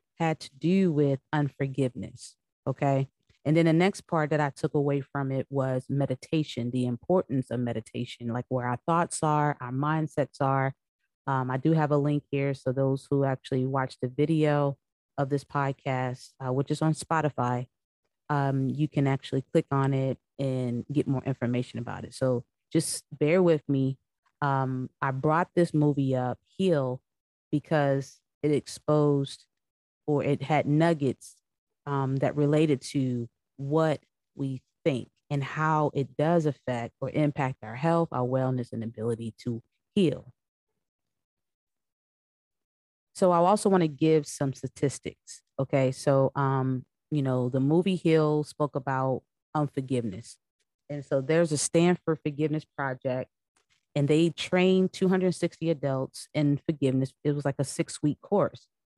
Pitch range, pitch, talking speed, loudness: 130-150 Hz, 140 Hz, 150 wpm, -28 LUFS